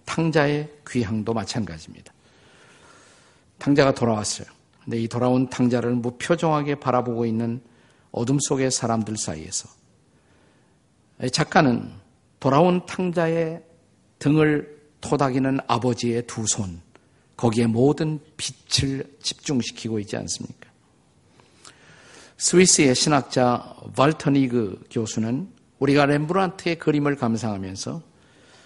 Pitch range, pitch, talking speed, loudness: 115-150 Hz, 130 Hz, 255 characters per minute, -22 LUFS